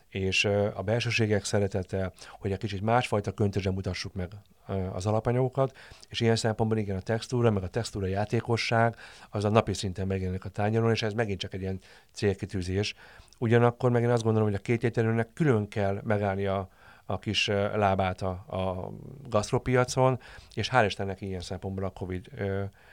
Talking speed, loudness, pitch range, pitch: 160 wpm, -29 LUFS, 95-115 Hz, 105 Hz